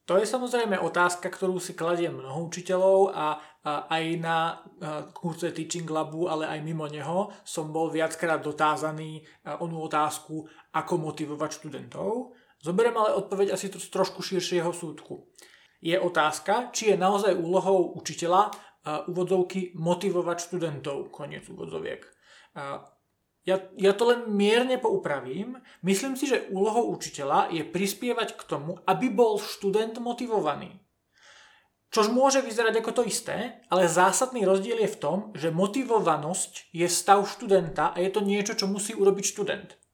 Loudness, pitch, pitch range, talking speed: -27 LUFS, 185 Hz, 165-205 Hz, 145 wpm